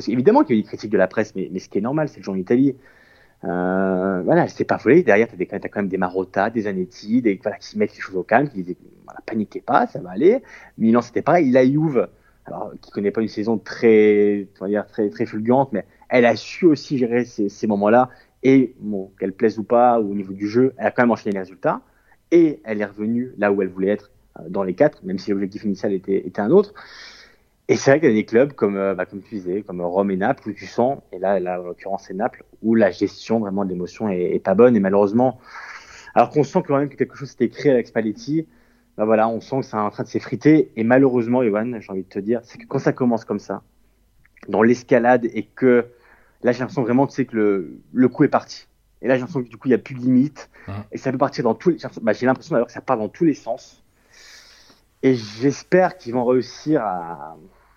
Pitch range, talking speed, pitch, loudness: 100-130 Hz, 260 wpm, 115 Hz, -20 LUFS